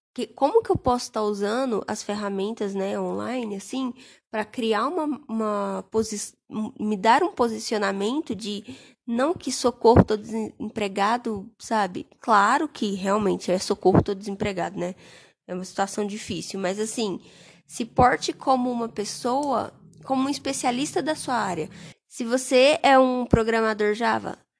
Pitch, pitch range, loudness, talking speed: 220 Hz, 205-255 Hz, -24 LUFS, 140 wpm